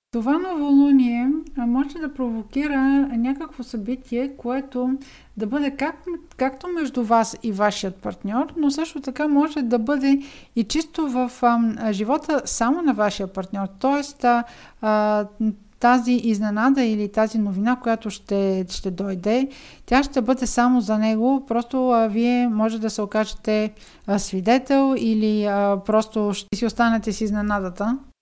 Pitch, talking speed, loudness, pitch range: 240 Hz, 140 wpm, -22 LUFS, 215-270 Hz